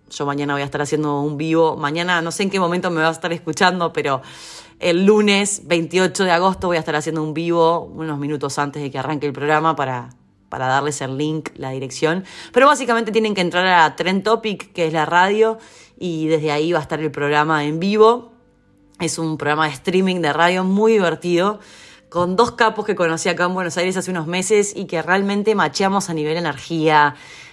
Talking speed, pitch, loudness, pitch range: 210 wpm, 170 Hz, -18 LUFS, 155-185 Hz